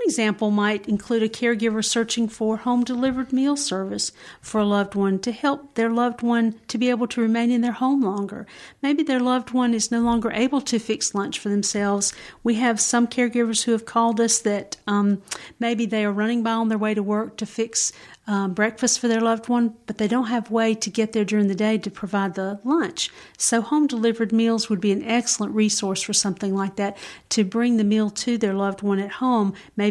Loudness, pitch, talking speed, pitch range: -22 LUFS, 225 Hz, 215 wpm, 205-235 Hz